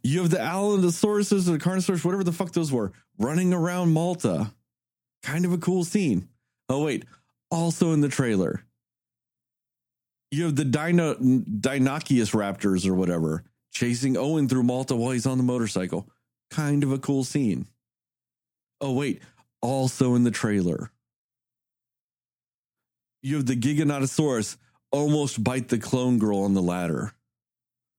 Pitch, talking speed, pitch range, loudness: 130 Hz, 140 wpm, 110-165 Hz, -25 LUFS